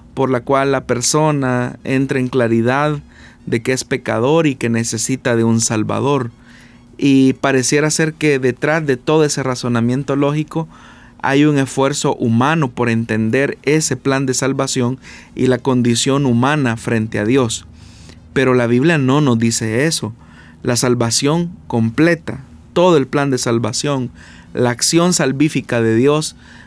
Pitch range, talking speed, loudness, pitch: 120-140 Hz, 145 wpm, -16 LUFS, 130 Hz